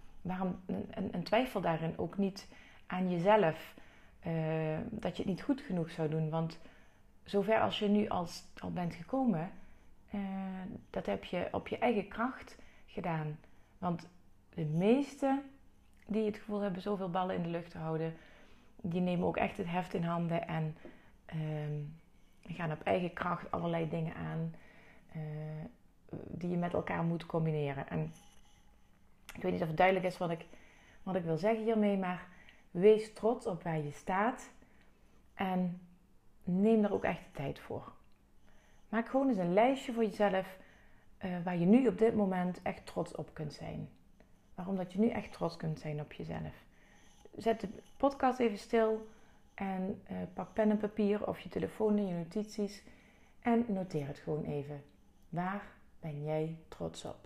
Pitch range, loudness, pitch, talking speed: 165-215 Hz, -35 LUFS, 185 Hz, 170 wpm